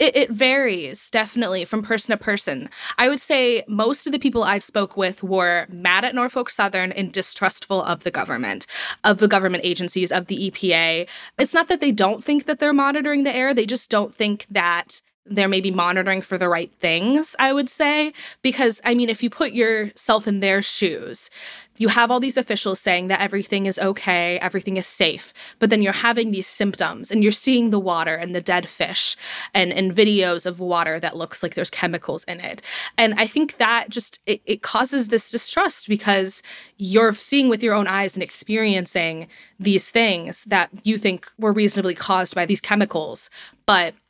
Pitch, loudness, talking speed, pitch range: 210 Hz, -20 LUFS, 195 wpm, 190-235 Hz